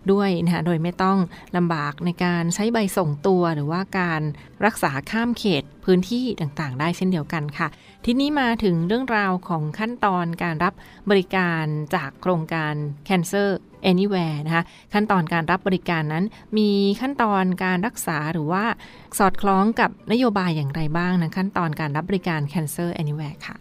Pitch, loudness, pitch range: 180 Hz, -22 LUFS, 165-200 Hz